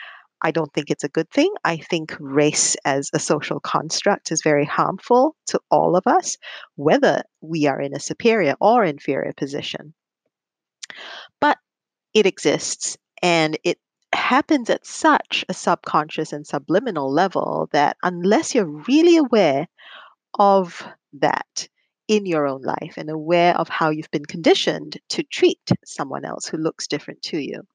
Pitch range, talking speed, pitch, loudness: 155-225 Hz, 150 wpm, 170 Hz, -20 LUFS